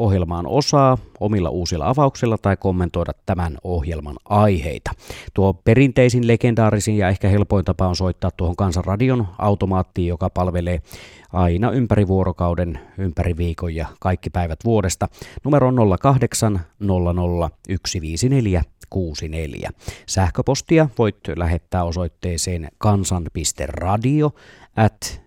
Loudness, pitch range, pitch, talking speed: -20 LUFS, 85-110 Hz, 95 Hz, 105 wpm